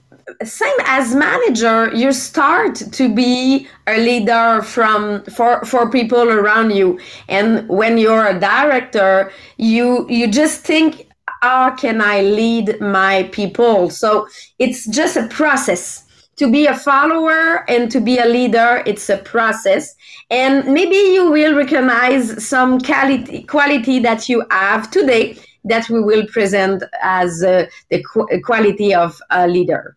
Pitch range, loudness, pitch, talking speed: 210-270 Hz, -14 LUFS, 235 Hz, 140 wpm